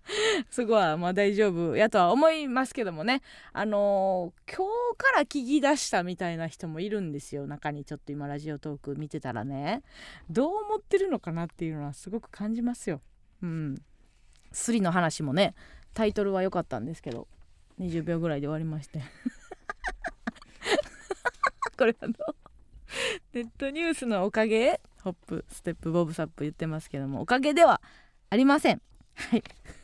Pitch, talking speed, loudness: 195 Hz, 325 characters per minute, -29 LUFS